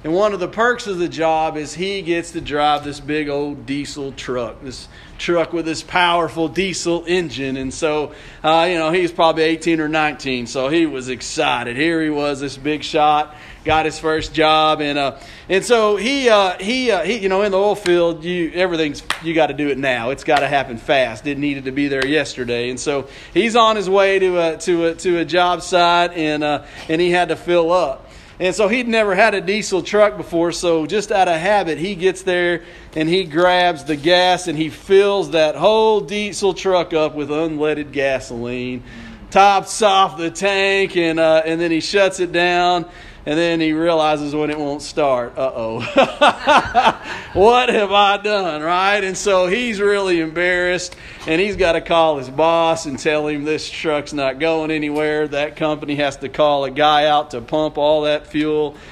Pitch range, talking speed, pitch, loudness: 150-180 Hz, 200 wpm, 160 Hz, -17 LUFS